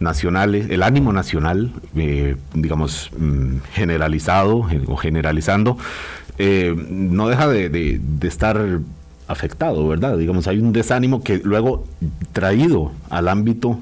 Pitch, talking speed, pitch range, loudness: 85 Hz, 115 wpm, 75-105 Hz, -19 LUFS